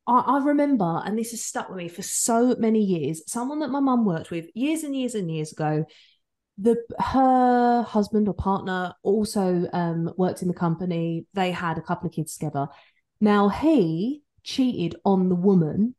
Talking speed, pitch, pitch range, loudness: 180 wpm, 200 Hz, 170-240 Hz, -24 LUFS